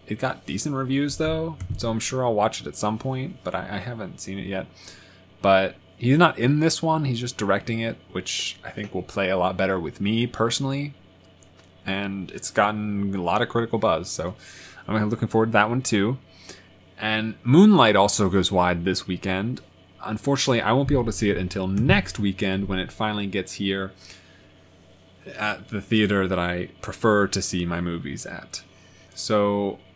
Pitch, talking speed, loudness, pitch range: 100 Hz, 185 wpm, -24 LUFS, 95-115 Hz